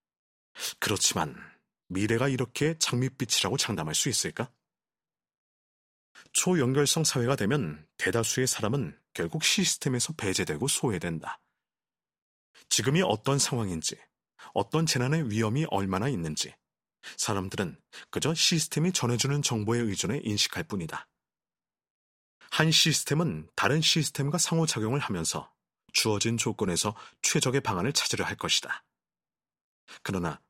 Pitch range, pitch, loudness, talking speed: 105-155 Hz, 125 Hz, -27 LUFS, 285 characters per minute